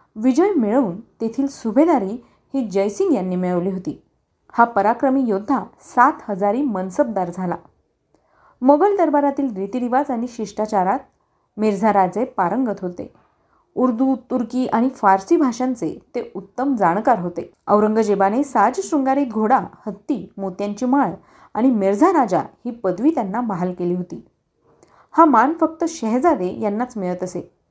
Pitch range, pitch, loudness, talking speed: 195-270 Hz, 235 Hz, -19 LUFS, 125 wpm